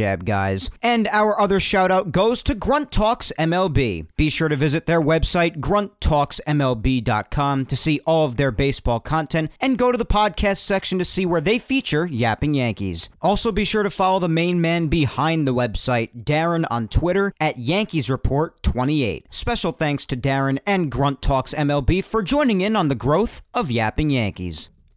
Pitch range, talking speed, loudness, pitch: 130-190 Hz, 175 wpm, -20 LUFS, 155 Hz